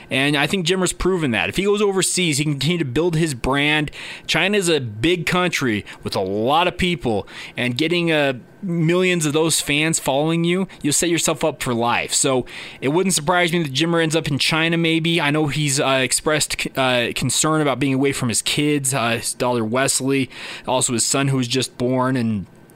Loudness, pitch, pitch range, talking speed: -19 LUFS, 150 Hz, 130-170 Hz, 210 wpm